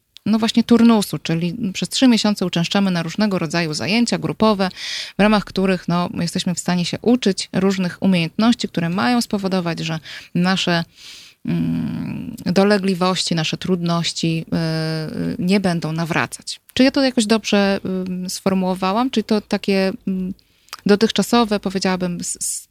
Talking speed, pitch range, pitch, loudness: 135 wpm, 170-210 Hz, 190 Hz, -19 LUFS